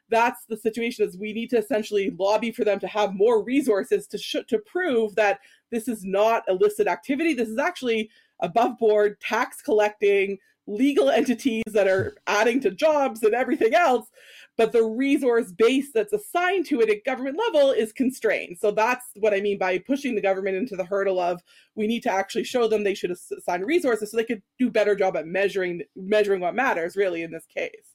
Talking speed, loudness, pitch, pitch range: 200 wpm, -23 LUFS, 225 Hz, 205-260 Hz